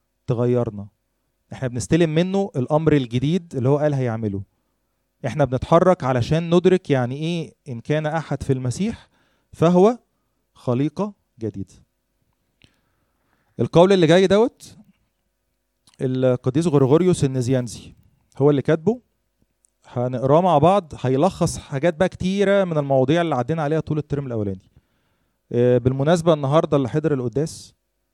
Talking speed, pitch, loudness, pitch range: 115 wpm, 145 Hz, -20 LUFS, 125-170 Hz